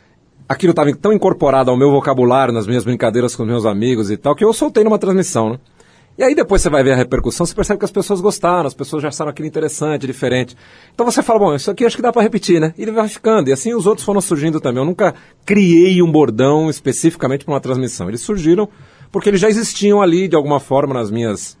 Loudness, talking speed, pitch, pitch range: -15 LUFS, 240 wpm, 155 Hz, 130-200 Hz